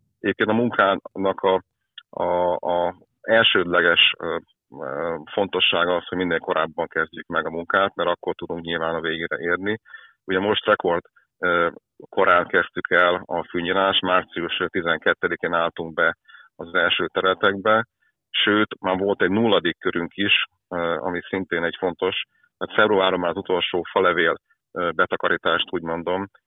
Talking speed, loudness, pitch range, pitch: 125 wpm, -22 LUFS, 90-110 Hz, 95 Hz